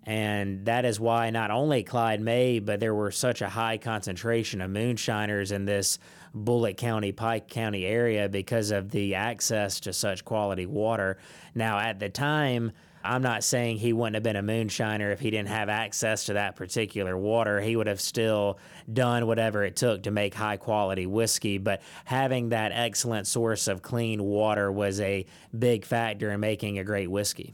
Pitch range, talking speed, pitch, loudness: 100-115 Hz, 185 wpm, 110 Hz, -28 LUFS